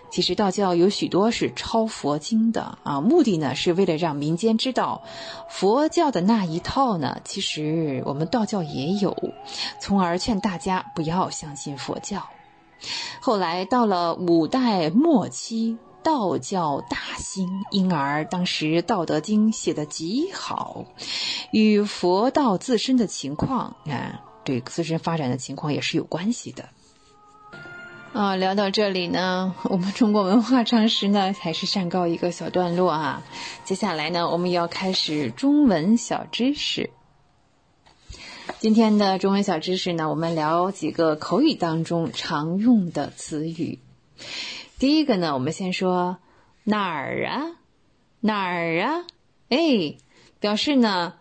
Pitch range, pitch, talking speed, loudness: 165-225 Hz, 190 Hz, 205 characters per minute, -23 LUFS